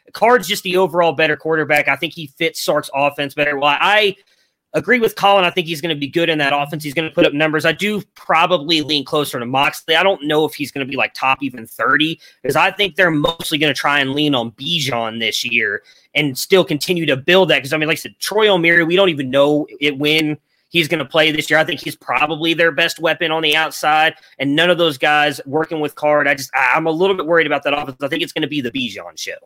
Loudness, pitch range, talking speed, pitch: -16 LUFS, 145-170 Hz, 265 wpm, 155 Hz